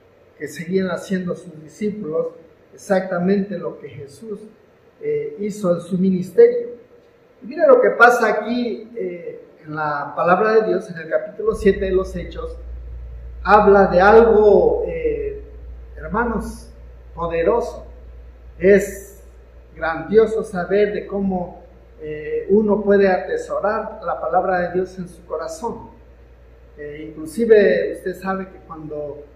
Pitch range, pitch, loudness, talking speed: 160-220 Hz, 190 Hz, -18 LUFS, 125 wpm